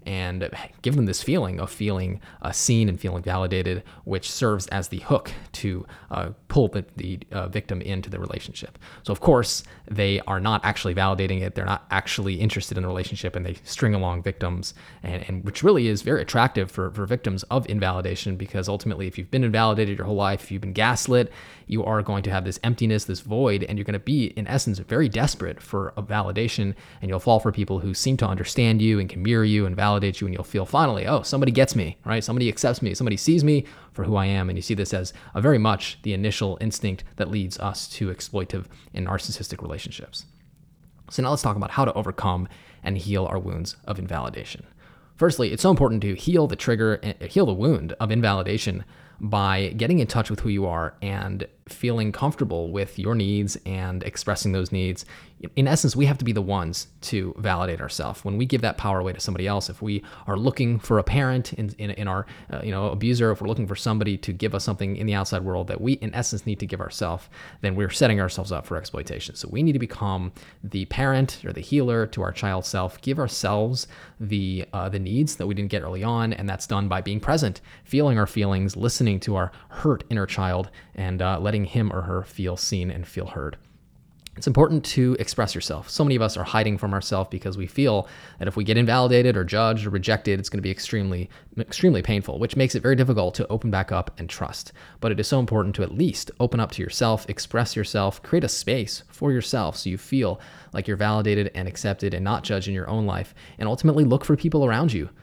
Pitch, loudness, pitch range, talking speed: 100 Hz, -24 LUFS, 95-115 Hz, 225 wpm